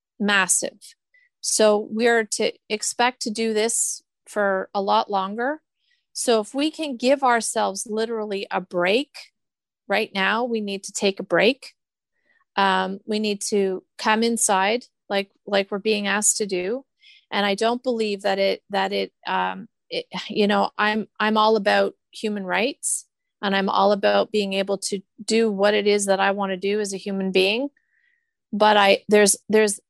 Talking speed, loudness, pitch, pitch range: 170 wpm, -22 LUFS, 210 Hz, 200-235 Hz